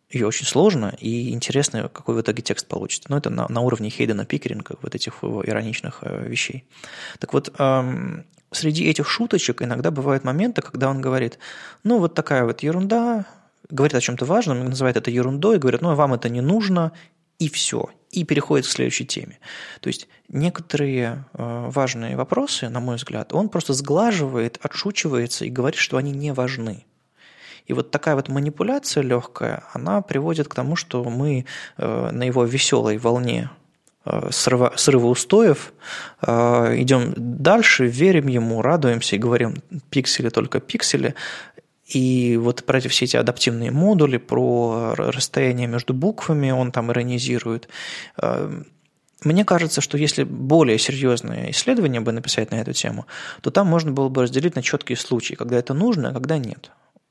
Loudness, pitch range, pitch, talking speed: -21 LUFS, 120-160 Hz, 135 Hz, 155 wpm